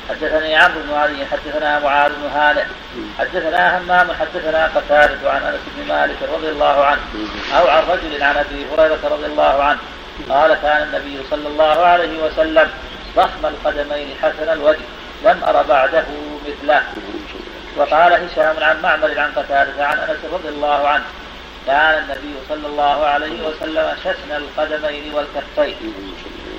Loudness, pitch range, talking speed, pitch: -16 LUFS, 145-155 Hz, 145 wpm, 150 Hz